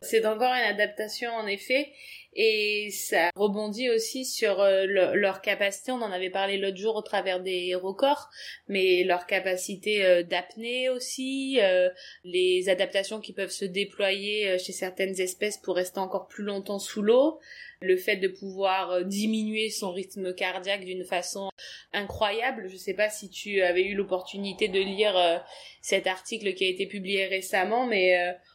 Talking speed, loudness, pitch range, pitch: 170 wpm, -27 LUFS, 185-215 Hz, 195 Hz